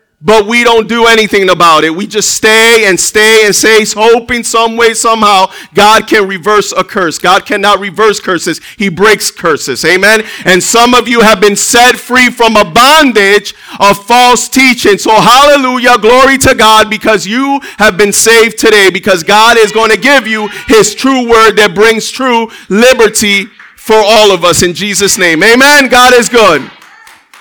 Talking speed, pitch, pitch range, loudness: 175 wpm, 220 Hz, 205-240 Hz, -5 LUFS